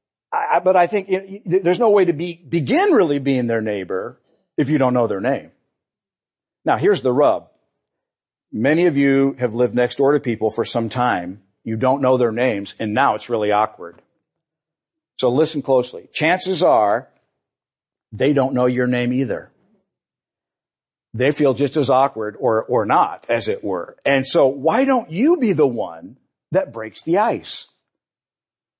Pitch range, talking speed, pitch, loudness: 125-170 Hz, 170 wpm, 135 Hz, -19 LUFS